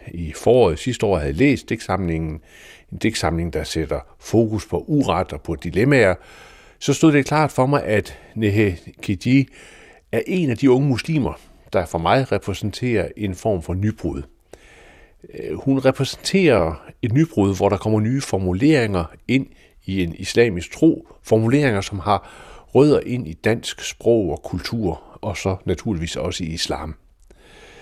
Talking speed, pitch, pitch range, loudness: 155 wpm, 105 Hz, 90-130 Hz, -20 LUFS